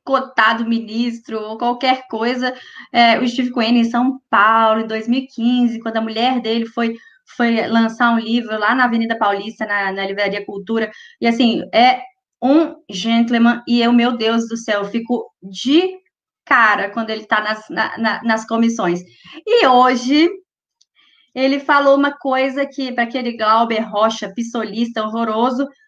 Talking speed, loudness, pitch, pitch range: 150 wpm, -17 LUFS, 235 Hz, 220-260 Hz